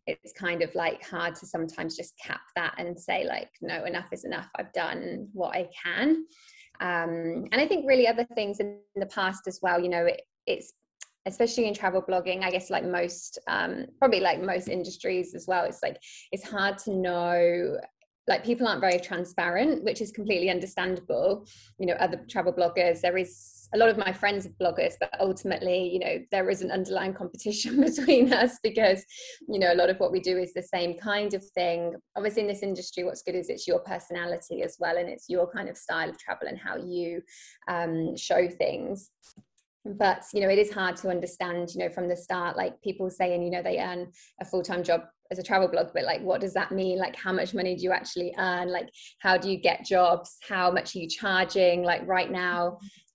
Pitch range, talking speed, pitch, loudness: 175-205 Hz, 215 wpm, 185 Hz, -28 LUFS